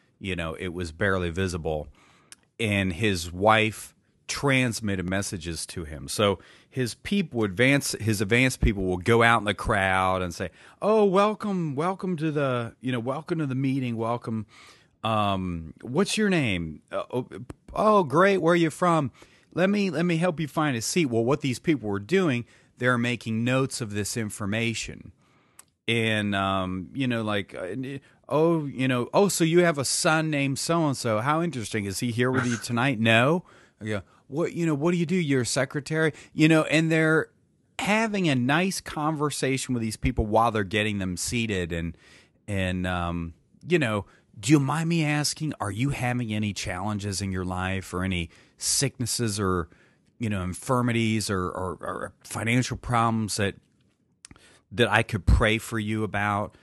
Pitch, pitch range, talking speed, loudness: 115 Hz, 100-150 Hz, 175 wpm, -25 LUFS